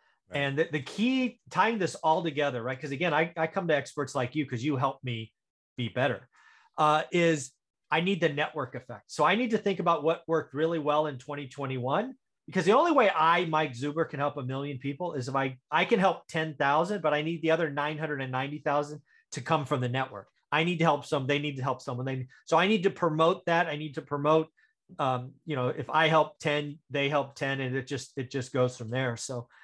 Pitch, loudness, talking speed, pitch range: 150 Hz, -29 LUFS, 240 wpm, 135-160 Hz